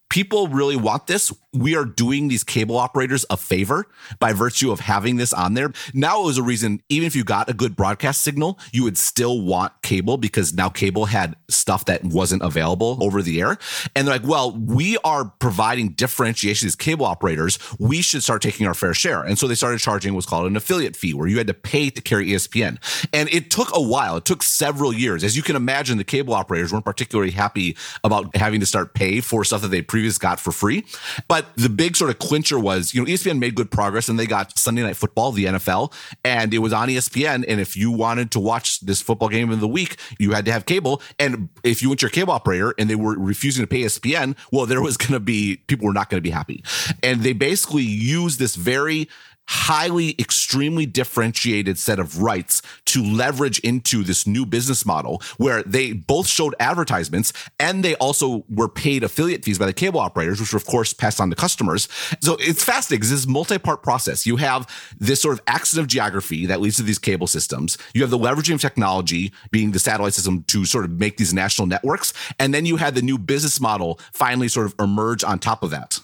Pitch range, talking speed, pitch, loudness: 105-135 Hz, 225 wpm, 115 Hz, -20 LUFS